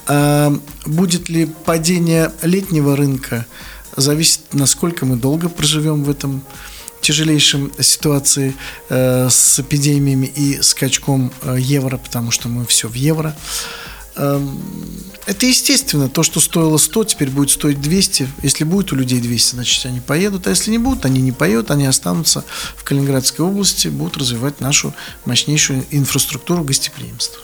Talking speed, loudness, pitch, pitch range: 135 wpm, -15 LUFS, 145 Hz, 135-165 Hz